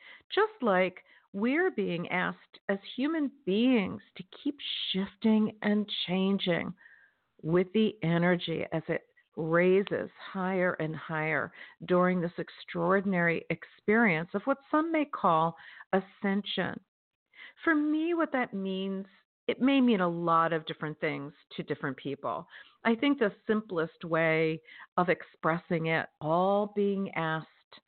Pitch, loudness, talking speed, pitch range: 190 Hz, -30 LUFS, 125 wpm, 165-220 Hz